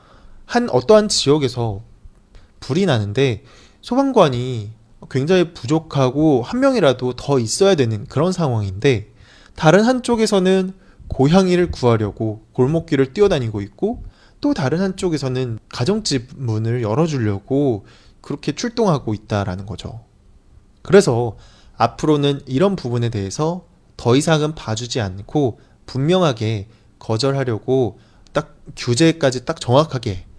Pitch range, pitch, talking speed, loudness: 110-160 Hz, 130 Hz, 280 characters per minute, -18 LUFS